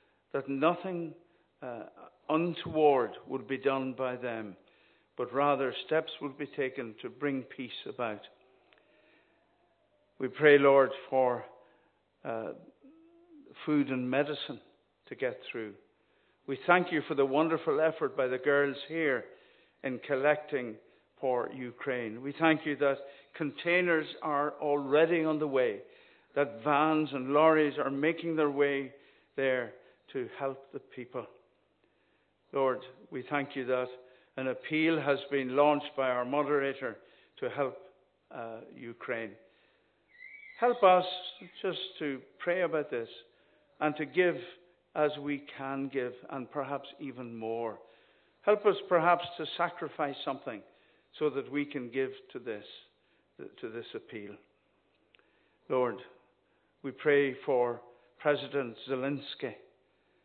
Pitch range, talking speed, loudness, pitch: 135-170 Hz, 125 wpm, -31 LUFS, 145 Hz